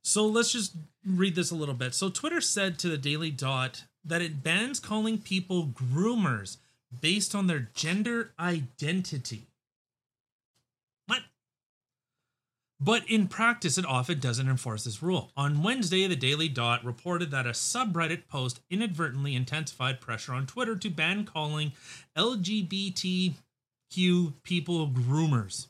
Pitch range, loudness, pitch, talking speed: 130-190 Hz, -29 LUFS, 160 Hz, 135 wpm